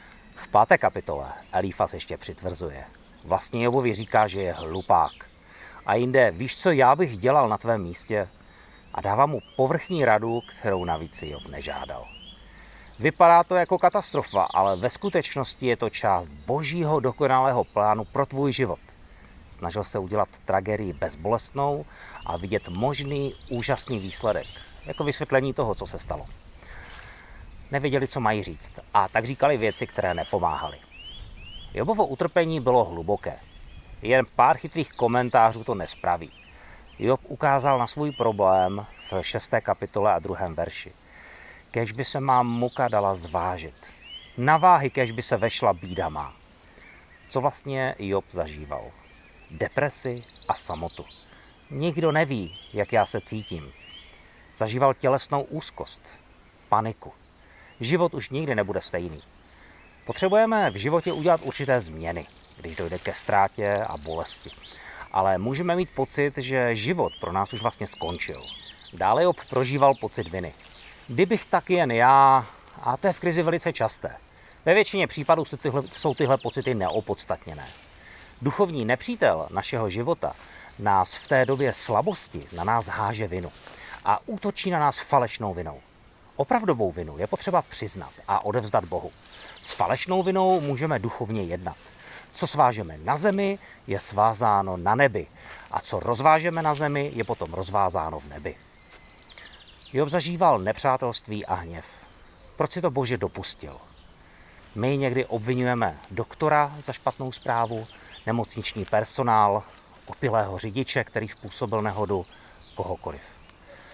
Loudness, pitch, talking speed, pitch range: -25 LUFS, 115 Hz, 135 wpm, 90-140 Hz